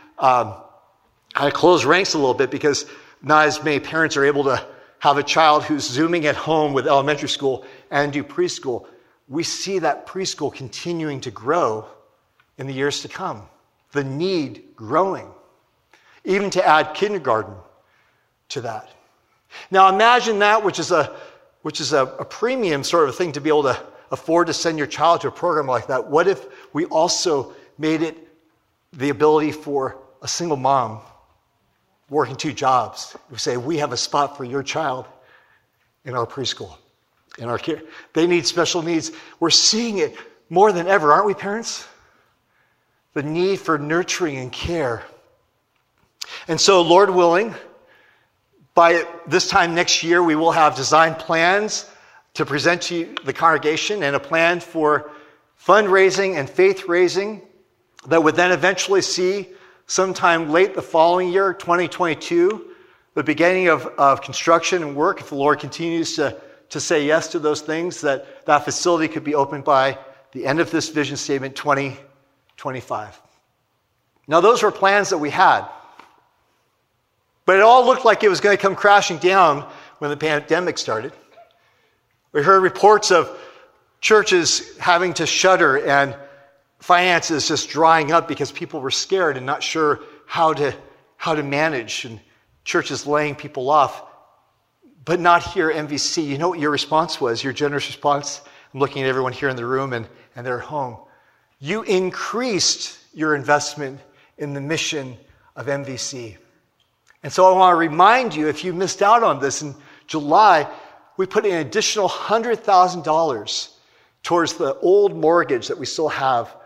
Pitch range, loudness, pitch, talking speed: 145-180 Hz, -18 LUFS, 160 Hz, 165 wpm